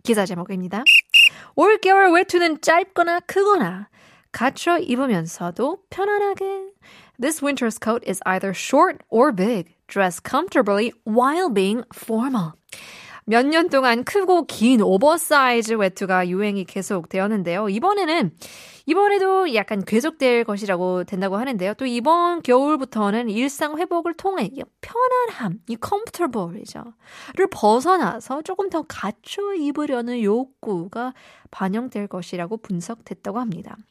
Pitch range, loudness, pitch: 205-340 Hz, -20 LUFS, 245 Hz